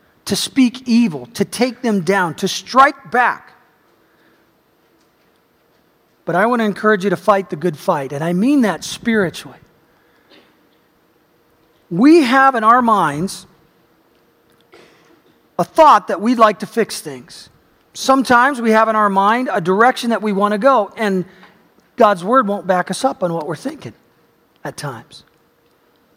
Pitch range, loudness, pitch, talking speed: 185-240 Hz, -15 LUFS, 210 Hz, 150 wpm